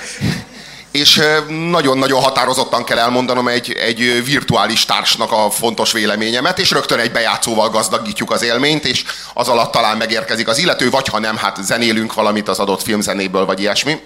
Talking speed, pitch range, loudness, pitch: 160 wpm, 110-135 Hz, -14 LUFS, 120 Hz